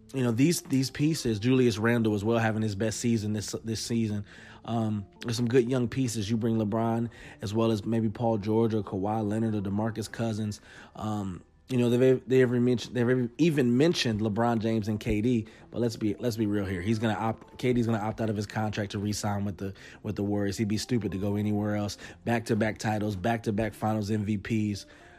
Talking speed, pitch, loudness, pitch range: 205 wpm, 110 Hz, -28 LUFS, 105-120 Hz